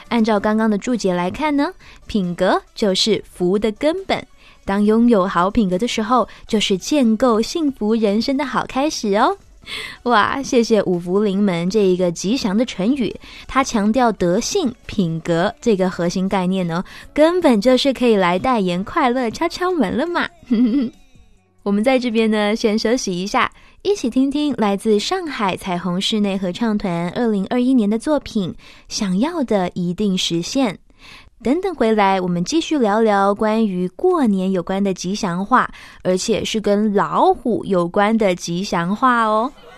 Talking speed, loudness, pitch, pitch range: 240 characters per minute, -18 LUFS, 215 Hz, 190-255 Hz